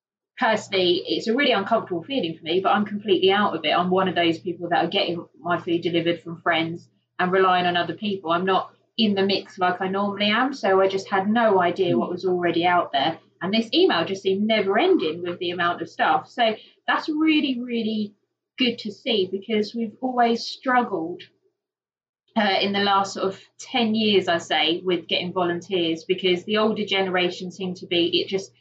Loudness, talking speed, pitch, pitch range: -22 LUFS, 205 wpm, 195 Hz, 175-225 Hz